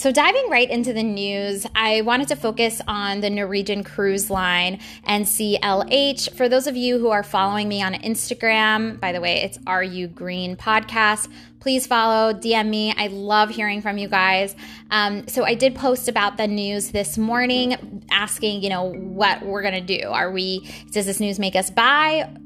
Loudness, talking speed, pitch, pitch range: -20 LUFS, 180 wpm, 210 Hz, 200-230 Hz